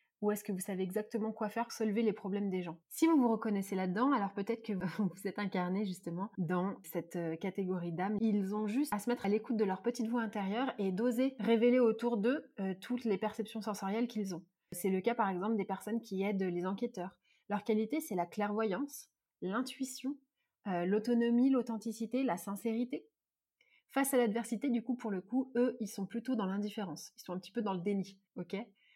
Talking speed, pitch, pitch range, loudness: 205 wpm, 215 Hz, 195-235 Hz, -36 LUFS